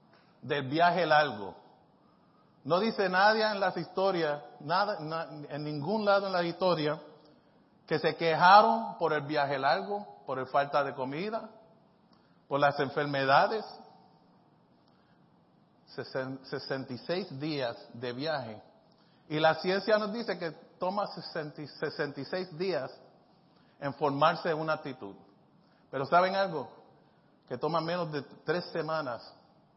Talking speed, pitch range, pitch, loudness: 120 wpm, 145-185 Hz, 155 Hz, -30 LUFS